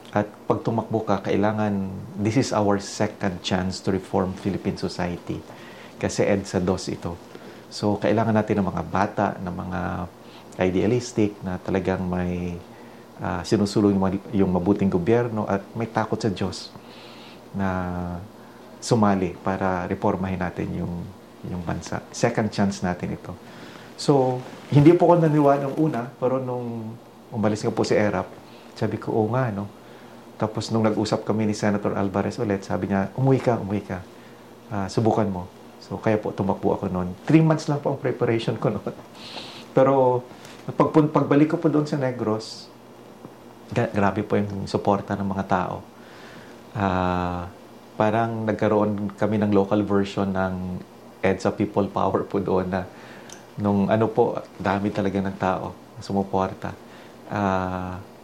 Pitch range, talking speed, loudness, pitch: 95-120 Hz, 150 wpm, -24 LUFS, 105 Hz